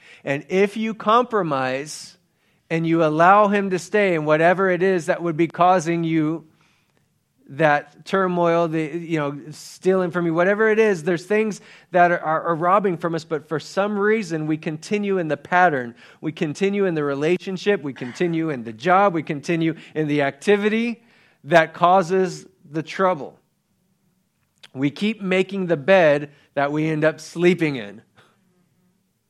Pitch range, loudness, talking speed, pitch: 155-190 Hz, -20 LUFS, 160 wpm, 170 Hz